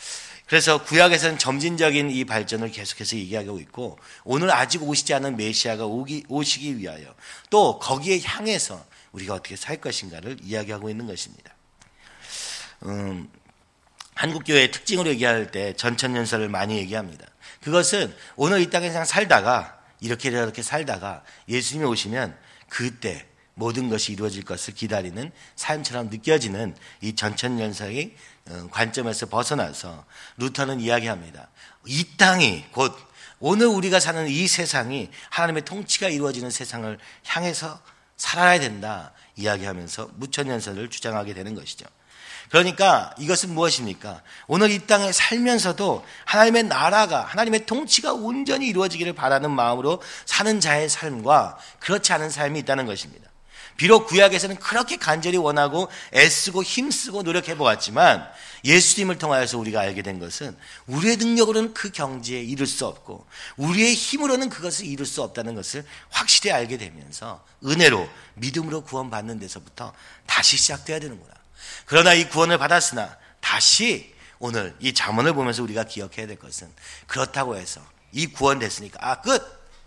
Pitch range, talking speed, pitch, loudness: 110-175 Hz, 350 characters per minute, 140 Hz, -21 LUFS